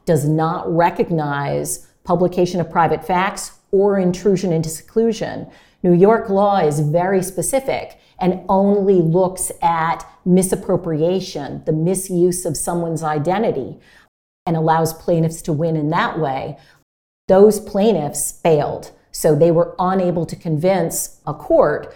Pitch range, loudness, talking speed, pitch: 160-190 Hz, -18 LUFS, 125 wpm, 175 Hz